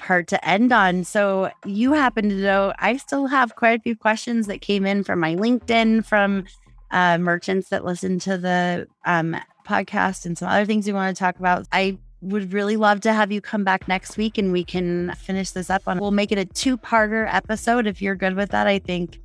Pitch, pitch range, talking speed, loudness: 195 Hz, 180-215 Hz, 220 wpm, -21 LUFS